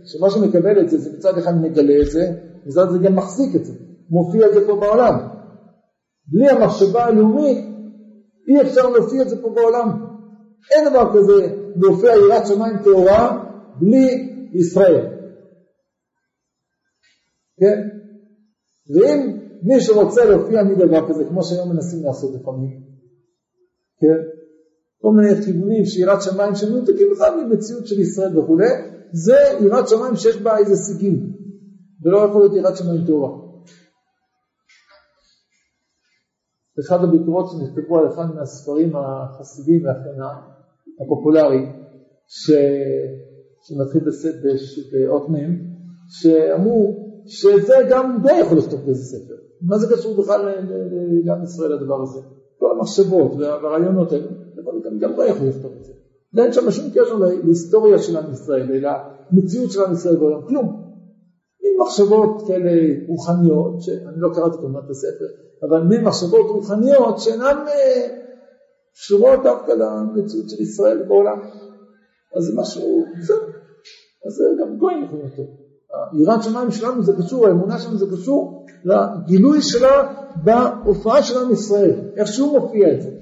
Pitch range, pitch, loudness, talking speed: 160-230 Hz, 195 Hz, -16 LUFS, 135 wpm